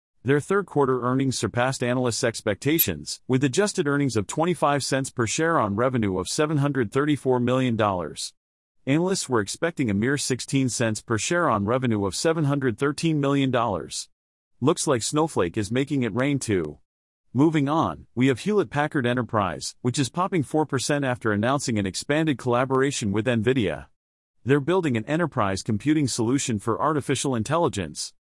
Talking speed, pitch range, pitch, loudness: 145 wpm, 115-145 Hz, 130 Hz, -24 LUFS